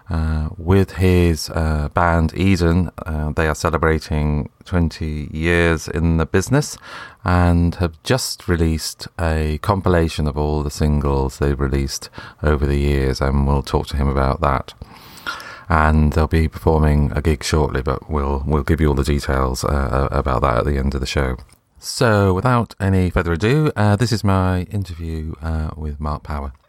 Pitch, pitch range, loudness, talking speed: 80 Hz, 75-90 Hz, -19 LUFS, 170 wpm